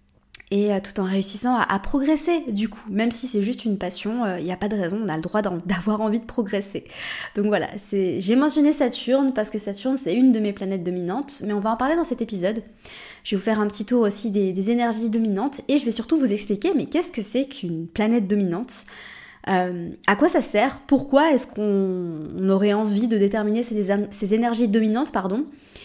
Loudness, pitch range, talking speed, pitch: -22 LUFS, 200-245 Hz, 220 wpm, 215 Hz